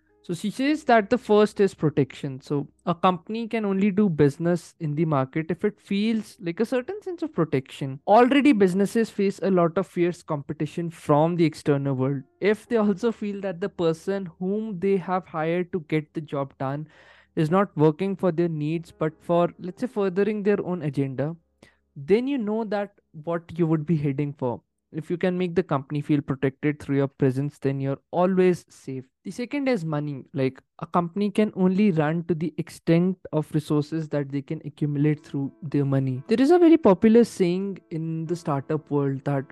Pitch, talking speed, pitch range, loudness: 170 Hz, 195 wpm, 150-200 Hz, -24 LUFS